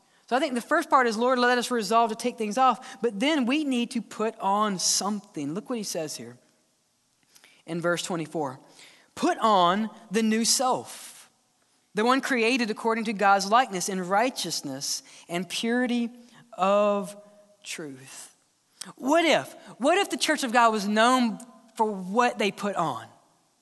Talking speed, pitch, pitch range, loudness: 165 wpm, 225 Hz, 195-245 Hz, -25 LUFS